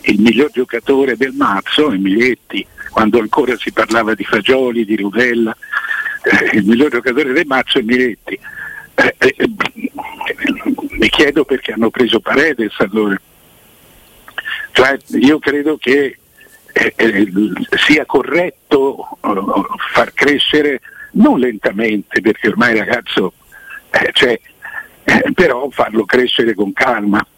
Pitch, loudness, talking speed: 130 Hz, -13 LUFS, 125 wpm